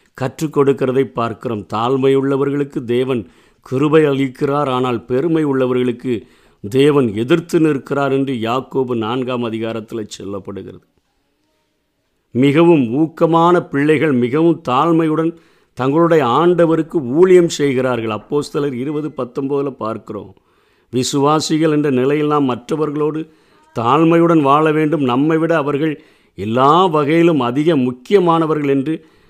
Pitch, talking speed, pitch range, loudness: 140 Hz, 95 wpm, 125-160 Hz, -15 LUFS